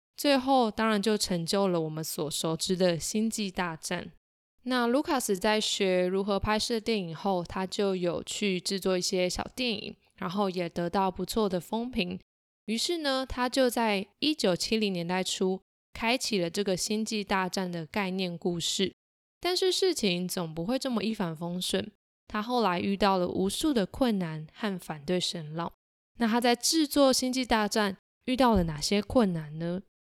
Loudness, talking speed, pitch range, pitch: -29 LUFS, 250 characters per minute, 180-230 Hz, 200 Hz